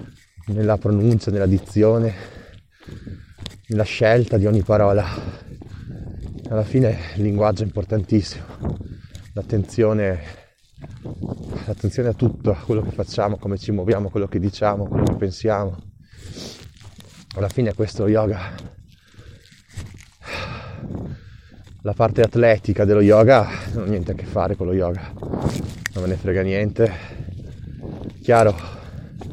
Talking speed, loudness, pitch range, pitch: 115 wpm, -20 LUFS, 95-110 Hz, 105 Hz